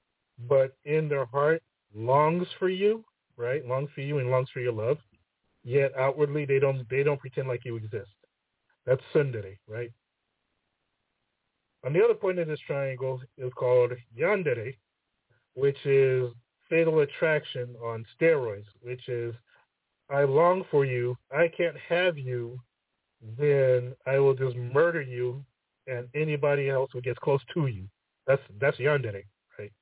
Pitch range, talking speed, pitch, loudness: 120-145 Hz, 145 wpm, 130 Hz, -27 LUFS